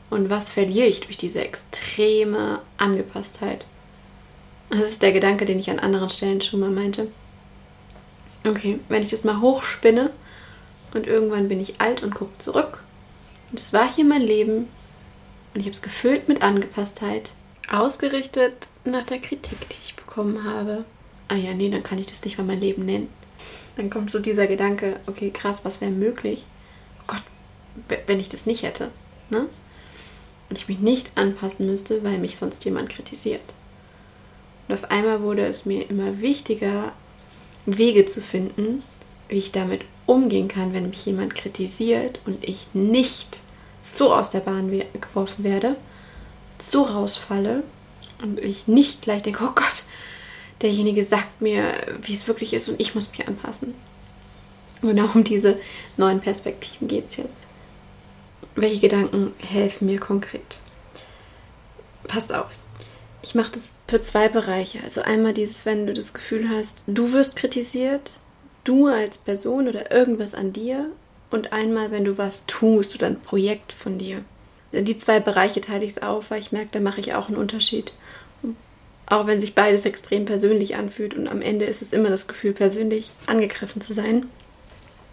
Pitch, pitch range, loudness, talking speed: 210 Hz, 200-225 Hz, -22 LUFS, 165 wpm